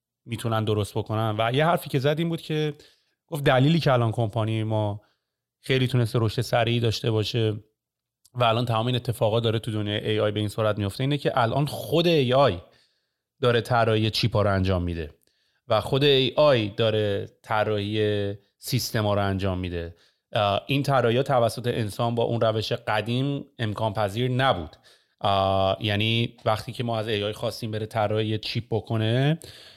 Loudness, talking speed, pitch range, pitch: -24 LUFS, 165 wpm, 105-125 Hz, 115 Hz